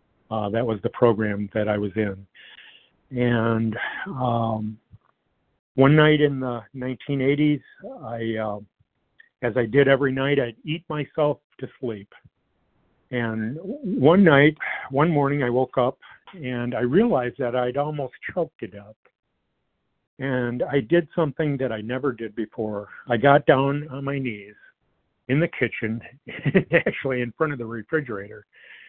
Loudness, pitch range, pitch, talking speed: -23 LUFS, 115-145 Hz, 125 Hz, 145 wpm